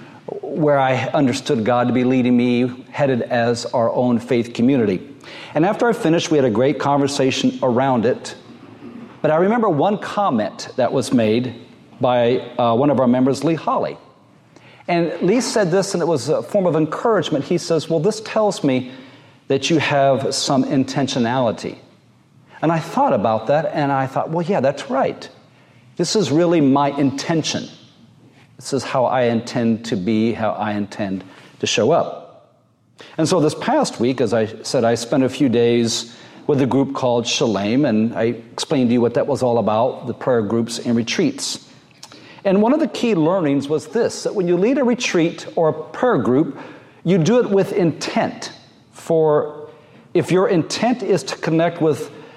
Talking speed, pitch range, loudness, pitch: 180 wpm, 120-165 Hz, -18 LUFS, 140 Hz